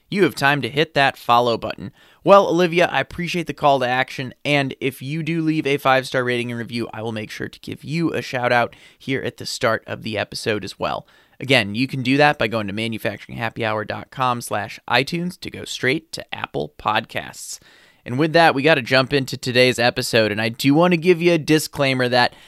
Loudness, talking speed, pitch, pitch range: -19 LUFS, 210 wpm, 130 Hz, 120-155 Hz